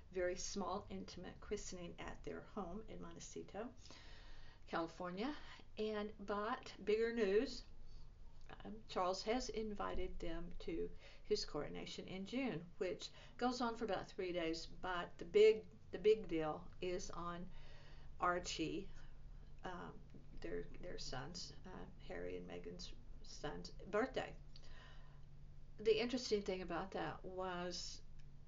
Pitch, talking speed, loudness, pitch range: 185 Hz, 120 wpm, -44 LUFS, 160-215 Hz